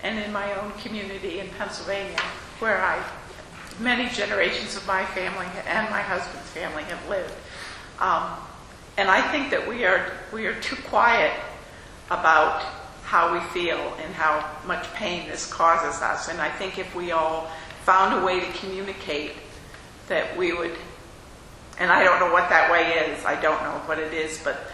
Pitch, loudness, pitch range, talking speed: 185 Hz, -24 LUFS, 160-195 Hz, 175 wpm